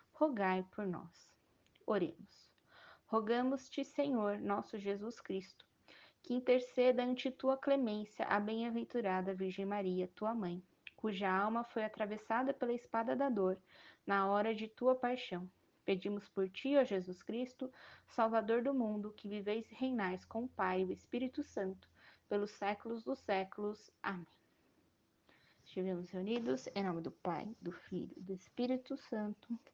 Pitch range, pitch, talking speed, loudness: 195-250 Hz, 215 Hz, 140 wpm, -39 LUFS